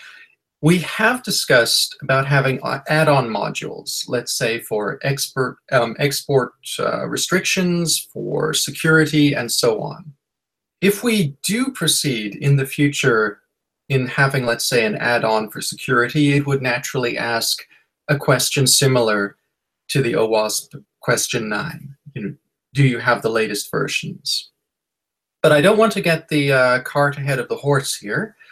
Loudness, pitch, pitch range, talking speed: -18 LUFS, 140 Hz, 130-155 Hz, 145 wpm